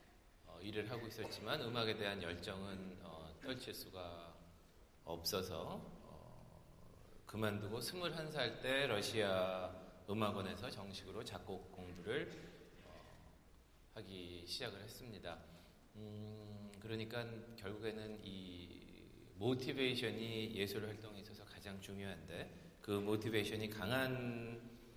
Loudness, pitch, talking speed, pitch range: -44 LUFS, 100 Hz, 235 characters per minute, 90-110 Hz